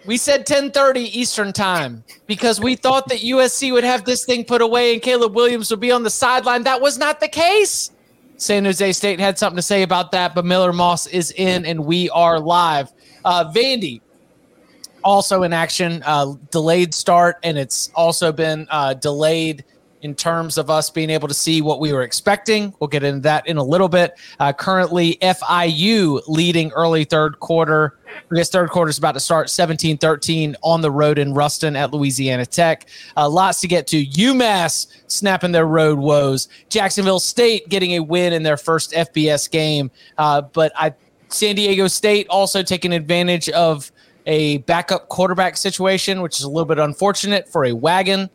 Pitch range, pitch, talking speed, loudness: 155-200 Hz, 175 Hz, 185 wpm, -17 LUFS